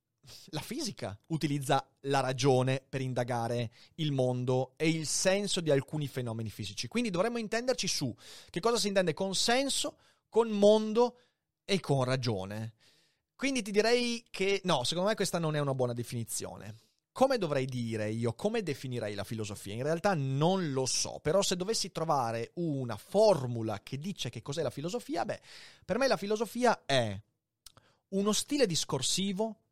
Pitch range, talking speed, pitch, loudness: 125-205 Hz, 160 wpm, 155 Hz, -31 LUFS